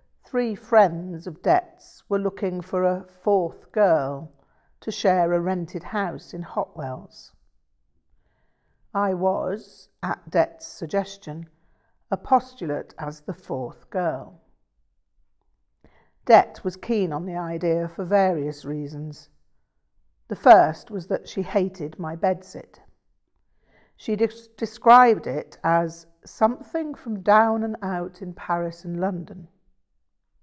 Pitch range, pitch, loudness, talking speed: 165-205 Hz, 185 Hz, -23 LUFS, 115 wpm